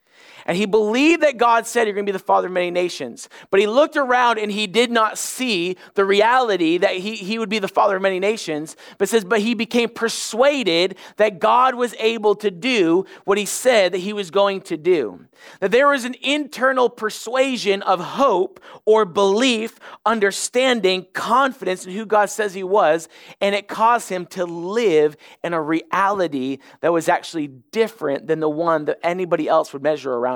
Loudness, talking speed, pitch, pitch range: -19 LUFS, 190 wpm, 210 Hz, 180-235 Hz